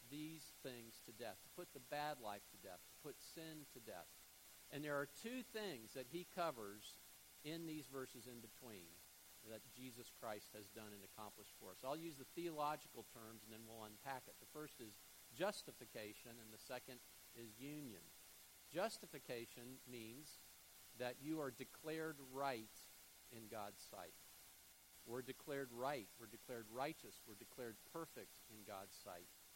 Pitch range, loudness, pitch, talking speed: 95-140 Hz, -53 LUFS, 115 Hz, 160 wpm